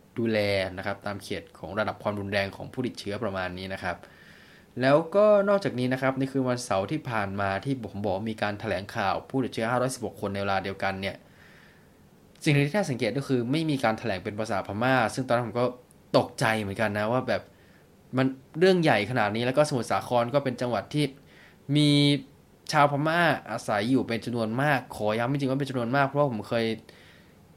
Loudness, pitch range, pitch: -27 LUFS, 105-135 Hz, 120 Hz